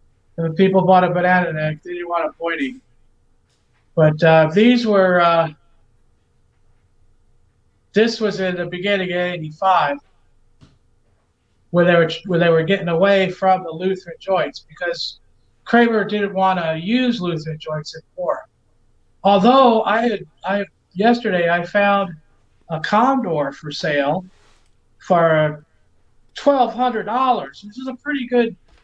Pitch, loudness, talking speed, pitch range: 170 Hz, -18 LUFS, 135 wpm, 120-195 Hz